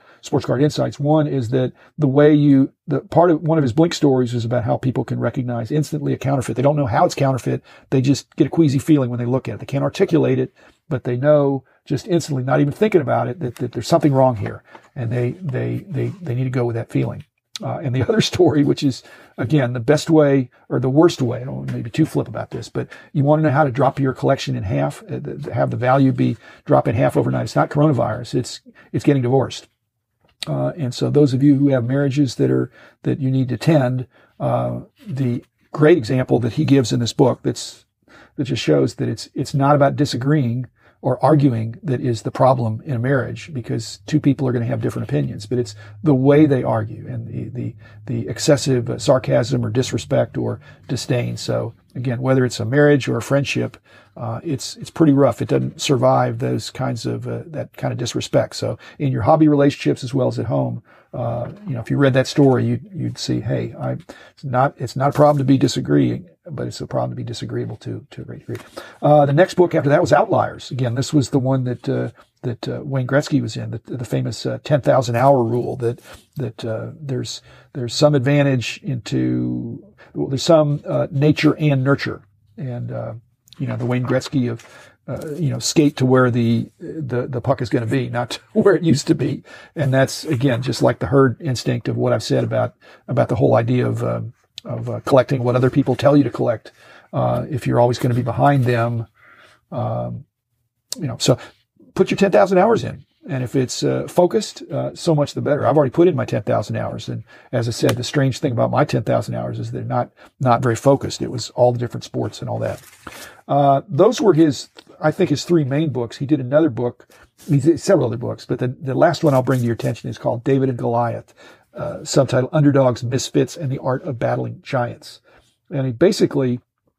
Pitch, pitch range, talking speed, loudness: 130 Hz, 120-145 Hz, 225 wpm, -19 LUFS